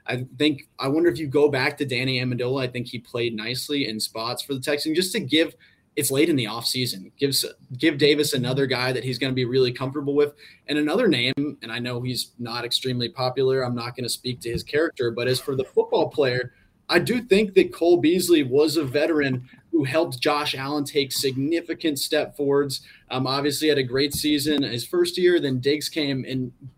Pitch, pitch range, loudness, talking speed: 140 Hz, 125-150 Hz, -23 LUFS, 215 wpm